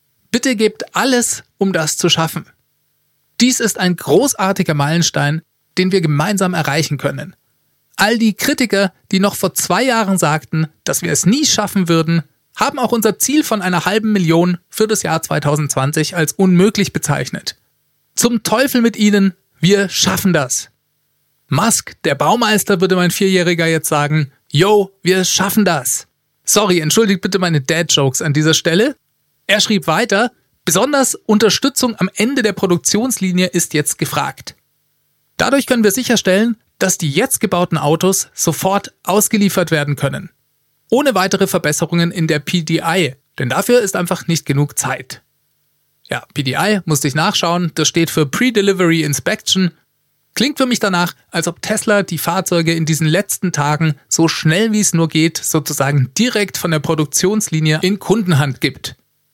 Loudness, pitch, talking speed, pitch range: -15 LUFS, 175 Hz, 150 wpm, 155-205 Hz